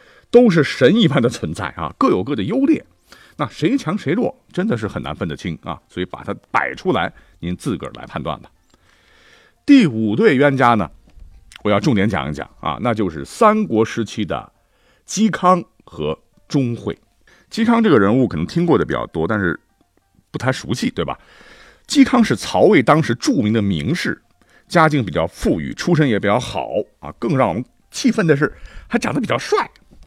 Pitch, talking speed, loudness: 140 Hz, 265 characters per minute, -18 LUFS